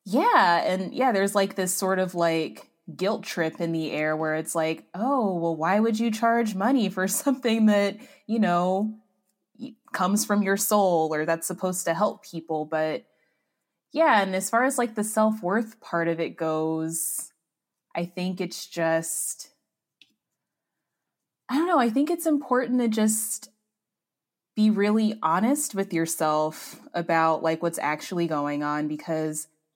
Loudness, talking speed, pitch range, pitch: -25 LUFS, 155 wpm, 165-220 Hz, 190 Hz